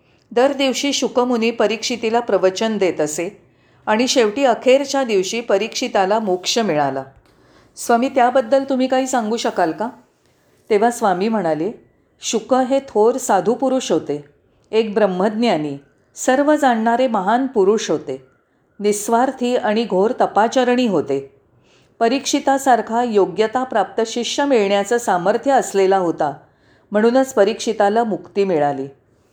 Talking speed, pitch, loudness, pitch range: 110 wpm, 225 Hz, -18 LUFS, 190-250 Hz